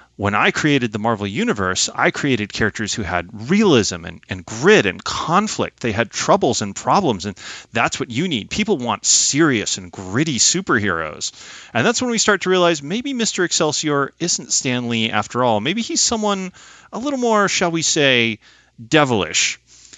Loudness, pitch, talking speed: -18 LUFS, 140 Hz, 175 wpm